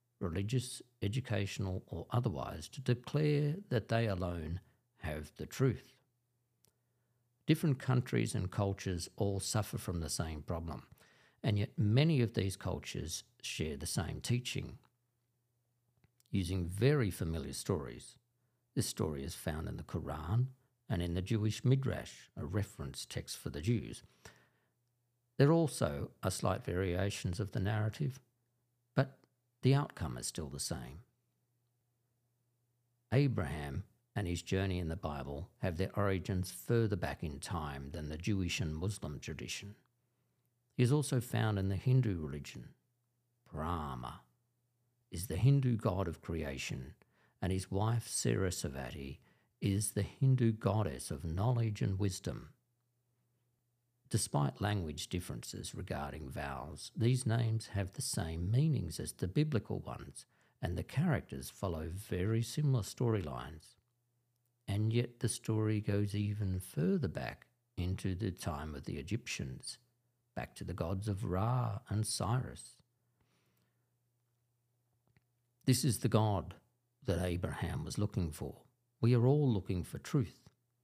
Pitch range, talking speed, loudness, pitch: 95-120 Hz, 130 wpm, -37 LUFS, 110 Hz